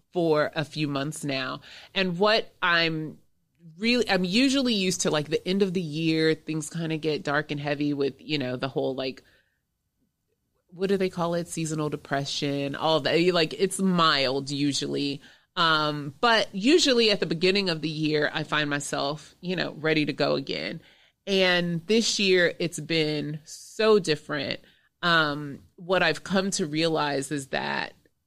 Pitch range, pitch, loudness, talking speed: 150-185 Hz, 160 Hz, -25 LUFS, 165 wpm